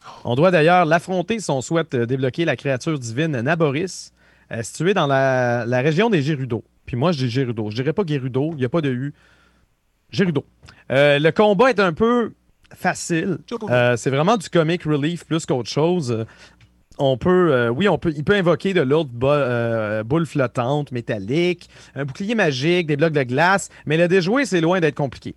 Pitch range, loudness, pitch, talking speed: 130-175 Hz, -20 LUFS, 155 Hz, 200 wpm